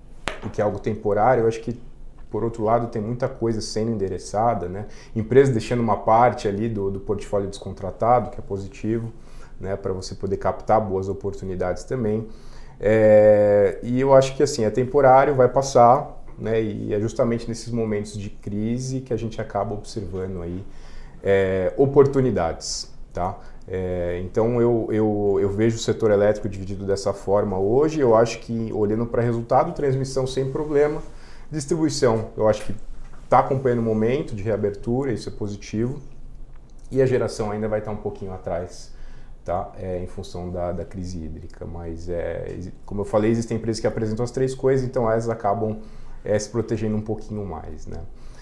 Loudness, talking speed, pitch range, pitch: -22 LUFS, 175 wpm, 100-125 Hz, 110 Hz